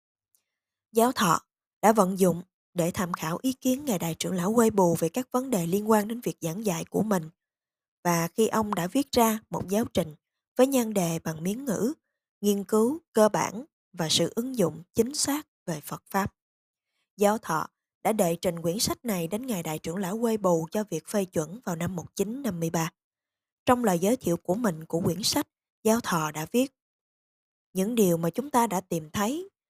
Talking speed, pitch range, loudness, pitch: 200 wpm, 170-230 Hz, -27 LUFS, 200 Hz